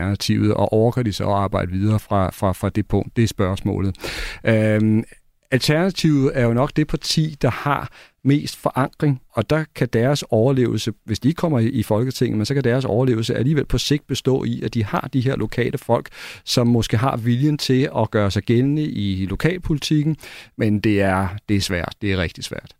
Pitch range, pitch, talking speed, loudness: 105-135 Hz, 120 Hz, 200 wpm, -20 LUFS